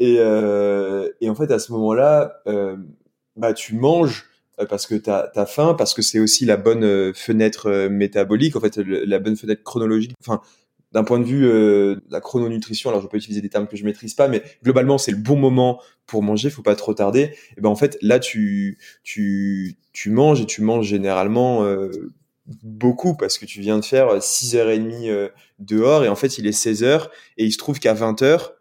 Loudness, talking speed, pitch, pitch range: -19 LUFS, 200 wpm, 110 Hz, 105-125 Hz